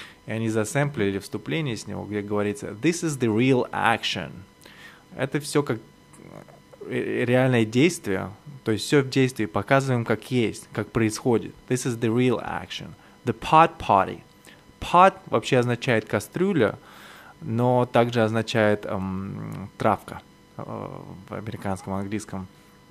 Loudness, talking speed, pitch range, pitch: -24 LUFS, 130 wpm, 105-130 Hz, 115 Hz